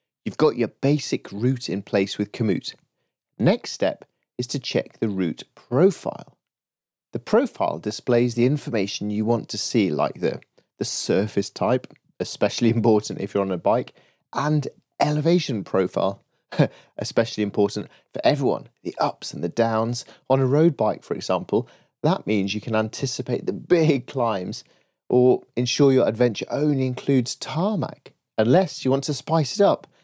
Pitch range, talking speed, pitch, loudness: 105-140 Hz, 155 wpm, 120 Hz, -23 LUFS